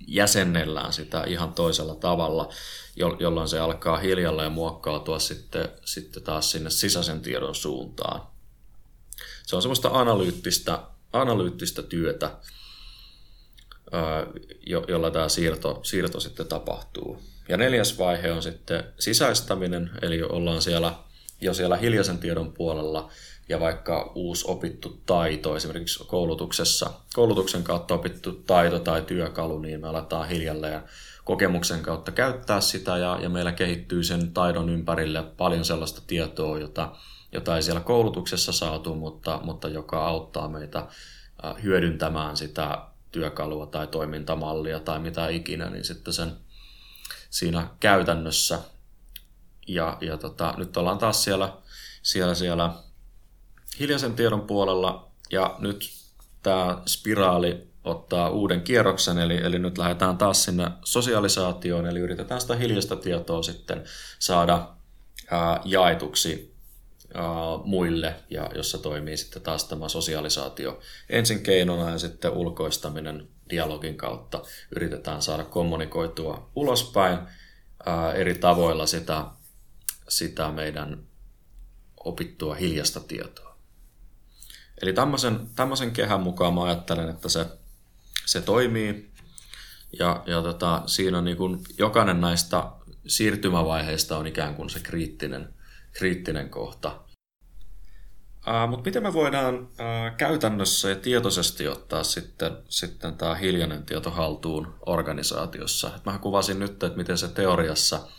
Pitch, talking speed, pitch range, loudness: 85 Hz, 115 wpm, 80-95 Hz, -26 LUFS